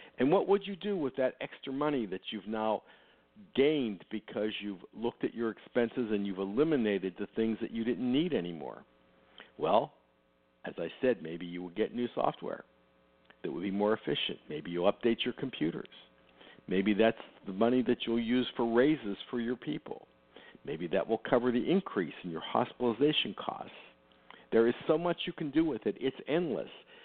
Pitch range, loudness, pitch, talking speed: 90-125 Hz, -33 LUFS, 110 Hz, 180 wpm